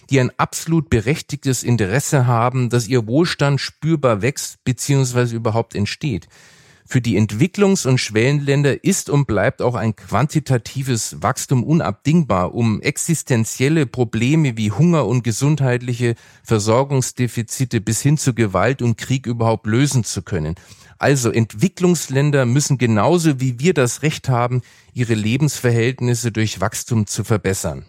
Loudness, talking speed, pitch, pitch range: -18 LUFS, 130 wpm, 125 Hz, 115-140 Hz